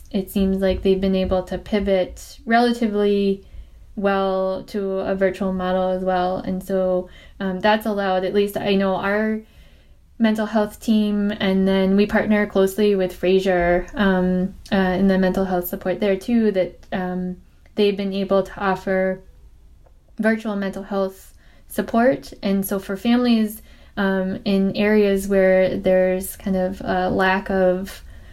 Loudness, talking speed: -20 LUFS, 150 wpm